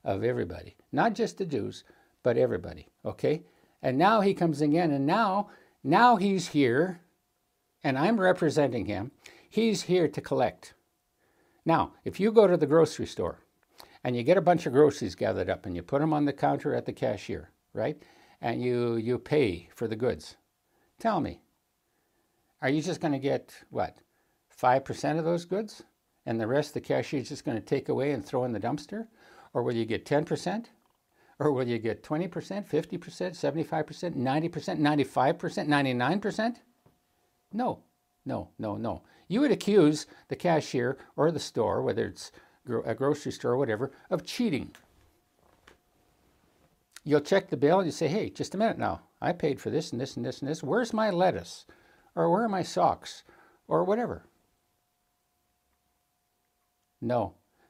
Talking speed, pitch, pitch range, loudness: 170 wpm, 155 Hz, 135-185 Hz, -28 LUFS